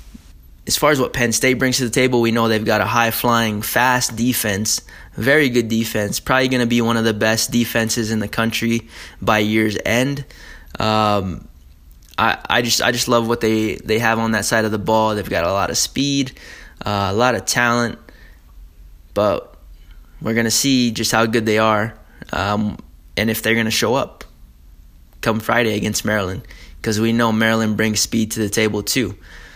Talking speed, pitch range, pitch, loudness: 195 wpm, 105-120 Hz, 110 Hz, -18 LUFS